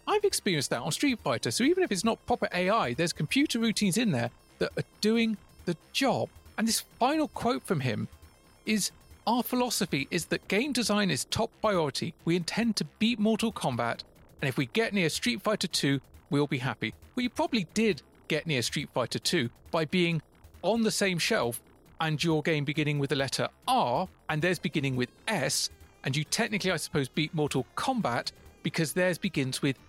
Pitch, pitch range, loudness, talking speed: 180 Hz, 145-225 Hz, -29 LUFS, 195 wpm